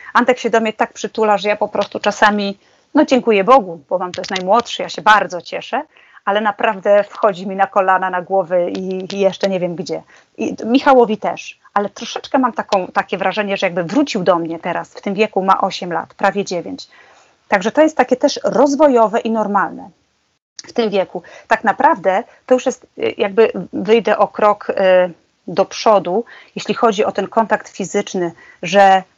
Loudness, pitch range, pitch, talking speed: -16 LUFS, 190-235 Hz, 205 Hz, 185 wpm